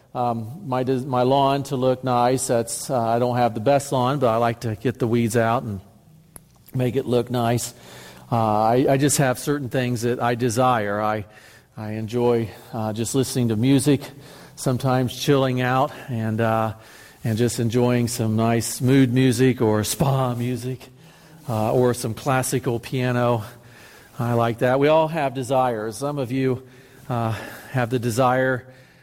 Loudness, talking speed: -22 LUFS, 165 wpm